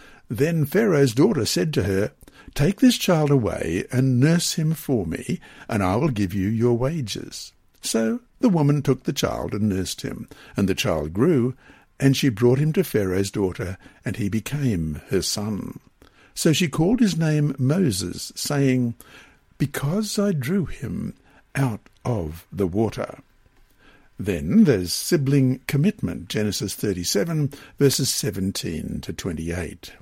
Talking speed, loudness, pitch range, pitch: 150 wpm, -23 LUFS, 105-155 Hz, 130 Hz